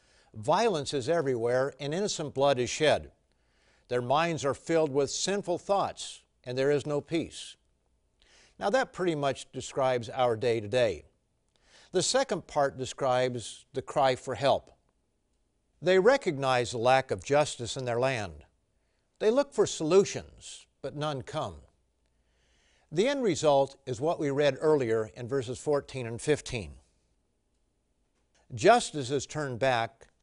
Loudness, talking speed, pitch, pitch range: -29 LUFS, 140 wpm, 130 Hz, 115-150 Hz